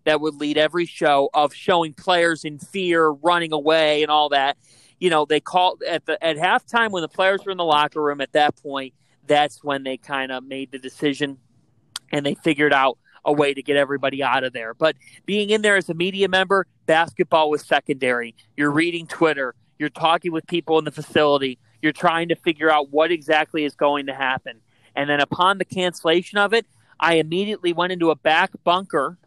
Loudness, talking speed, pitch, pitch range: -20 LUFS, 205 wpm, 155 Hz, 140-170 Hz